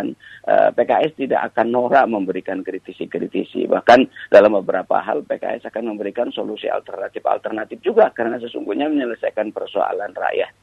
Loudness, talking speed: -19 LUFS, 125 wpm